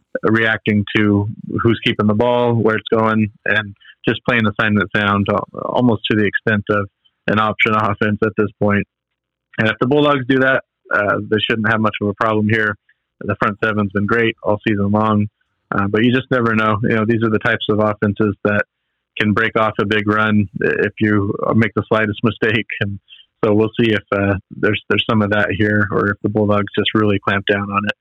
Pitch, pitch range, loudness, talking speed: 110 Hz, 105-115 Hz, -17 LUFS, 210 wpm